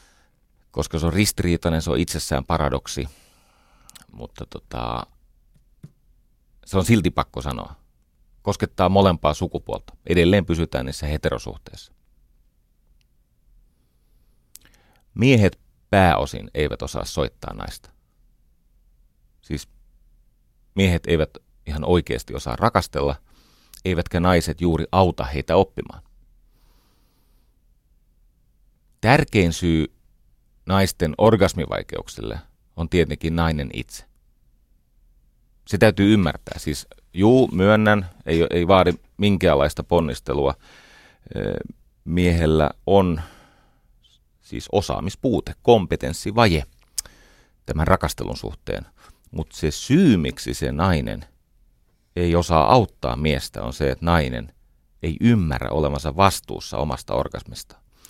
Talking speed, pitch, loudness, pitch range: 90 wpm, 80 Hz, -21 LUFS, 70-95 Hz